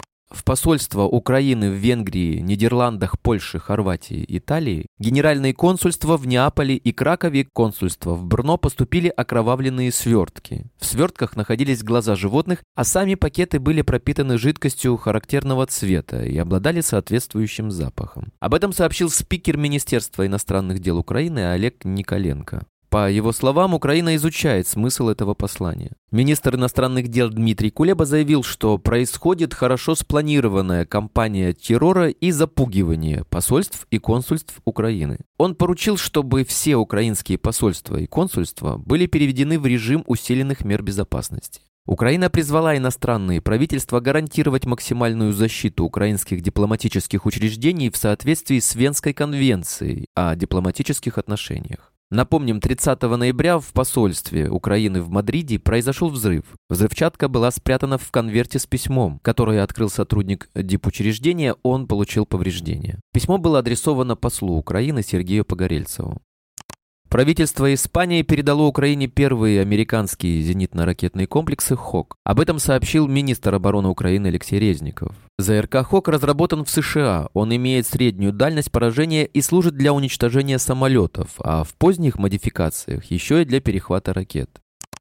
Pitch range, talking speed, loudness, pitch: 100-145 Hz, 125 wpm, -20 LUFS, 120 Hz